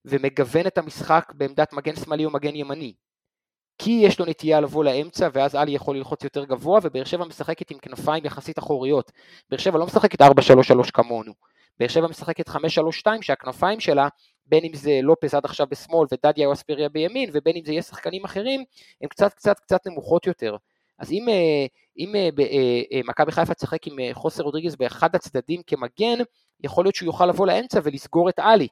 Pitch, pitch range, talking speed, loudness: 155 Hz, 140-175 Hz, 170 wpm, -22 LUFS